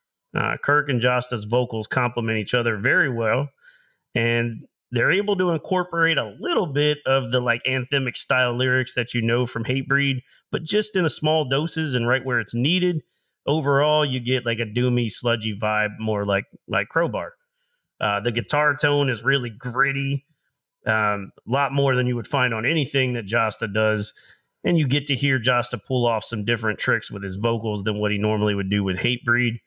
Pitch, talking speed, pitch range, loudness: 125 Hz, 190 wpm, 115-140 Hz, -22 LUFS